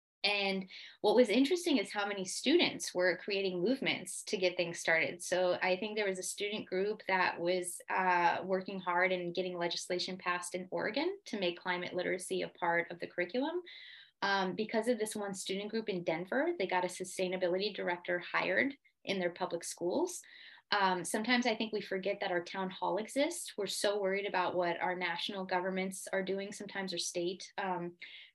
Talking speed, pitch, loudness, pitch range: 185 wpm, 190 Hz, -34 LUFS, 180-210 Hz